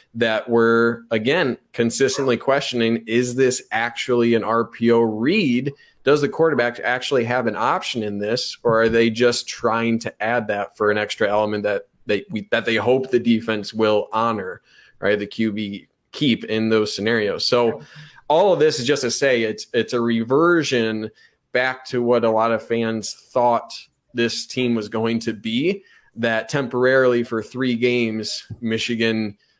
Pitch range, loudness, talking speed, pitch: 110-125 Hz, -20 LUFS, 165 wpm, 115 Hz